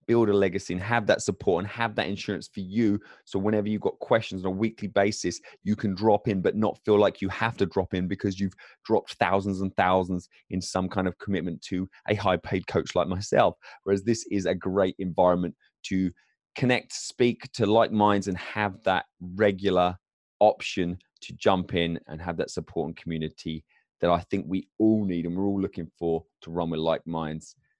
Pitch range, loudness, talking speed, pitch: 90-105 Hz, -27 LUFS, 205 wpm, 95 Hz